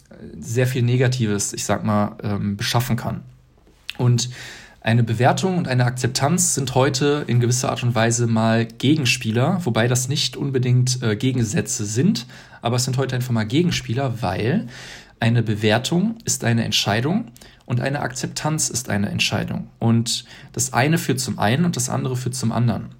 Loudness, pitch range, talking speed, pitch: -20 LUFS, 115-135 Hz, 160 wpm, 120 Hz